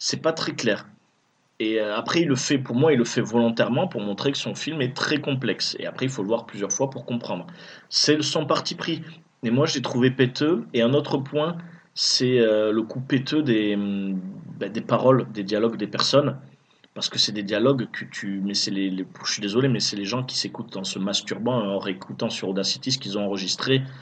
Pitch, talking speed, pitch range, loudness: 120 Hz, 220 wpm, 105-140 Hz, -24 LUFS